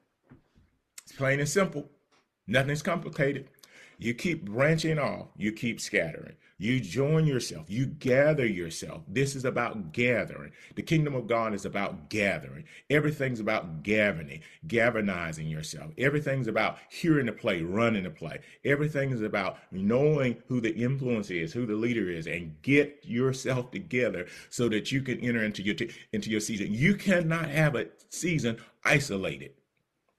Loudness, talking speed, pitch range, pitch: -29 LUFS, 150 wpm, 110-145 Hz, 125 Hz